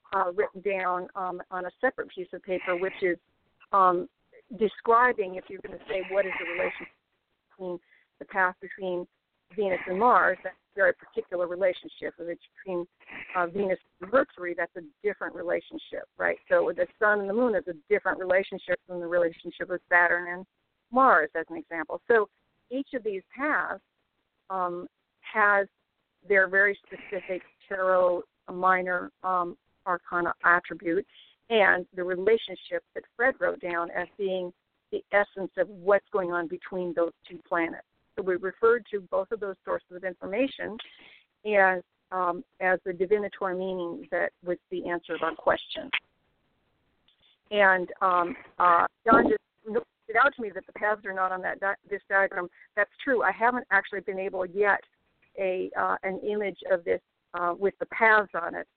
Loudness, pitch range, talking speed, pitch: -27 LUFS, 180-210 Hz, 165 wpm, 190 Hz